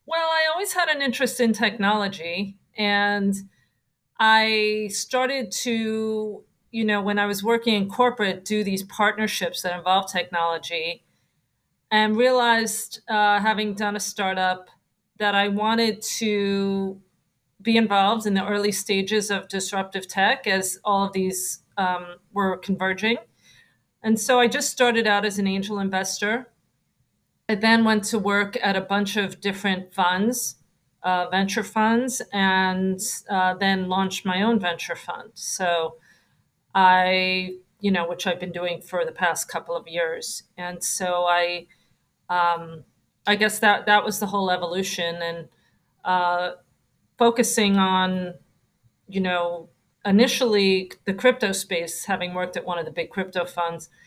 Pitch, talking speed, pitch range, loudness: 195 Hz, 145 wpm, 185-220 Hz, -23 LUFS